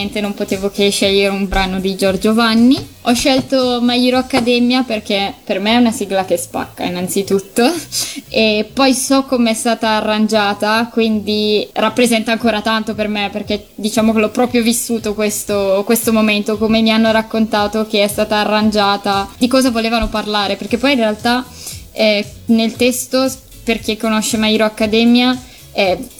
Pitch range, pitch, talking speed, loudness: 210-240 Hz, 220 Hz, 160 wpm, -15 LUFS